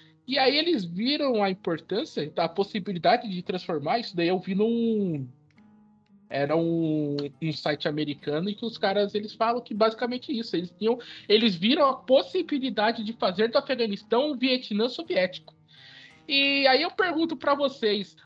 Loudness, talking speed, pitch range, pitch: -26 LUFS, 160 wpm, 175-255 Hz, 210 Hz